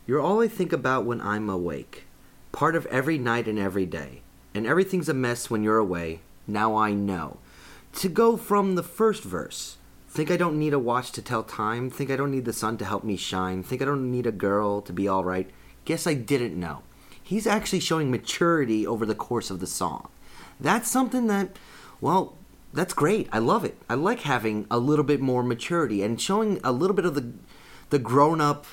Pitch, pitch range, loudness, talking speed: 125 Hz, 105-165 Hz, -26 LUFS, 210 wpm